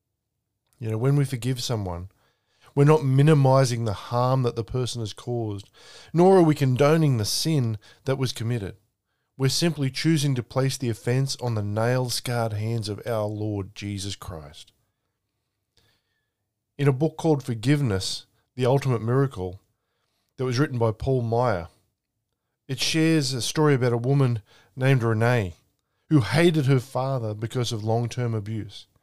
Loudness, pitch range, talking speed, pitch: -24 LUFS, 110-135 Hz, 155 wpm, 120 Hz